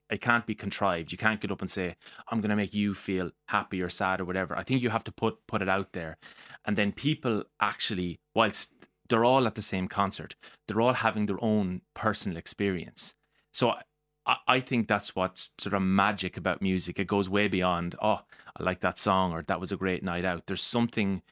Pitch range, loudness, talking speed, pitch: 95-110 Hz, -29 LUFS, 215 wpm, 100 Hz